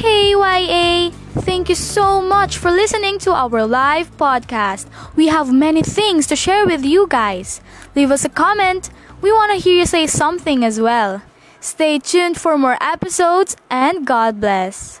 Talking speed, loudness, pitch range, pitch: 170 wpm, -15 LUFS, 275-375 Hz, 335 Hz